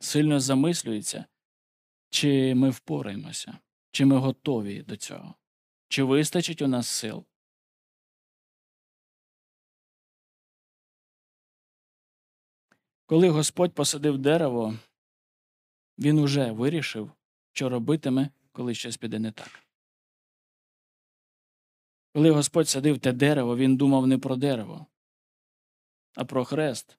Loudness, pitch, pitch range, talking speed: -25 LUFS, 135 Hz, 125-150 Hz, 95 wpm